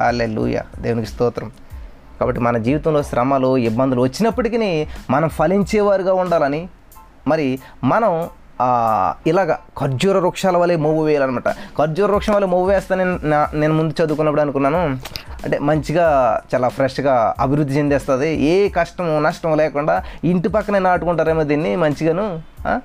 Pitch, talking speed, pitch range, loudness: 155 Hz, 120 wpm, 135-180 Hz, -18 LUFS